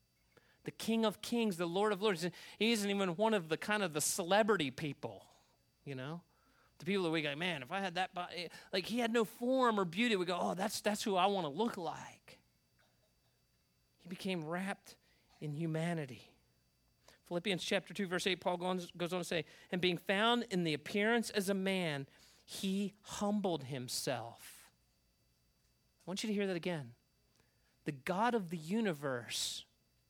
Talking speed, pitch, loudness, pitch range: 175 wpm, 180 Hz, -37 LUFS, 150-205 Hz